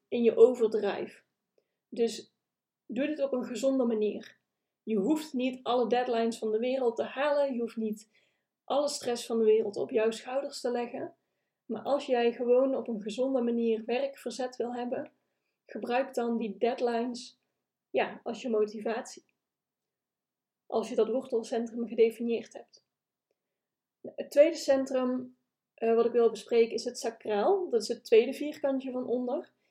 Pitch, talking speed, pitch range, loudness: 240 Hz, 150 wpm, 230-260 Hz, -30 LUFS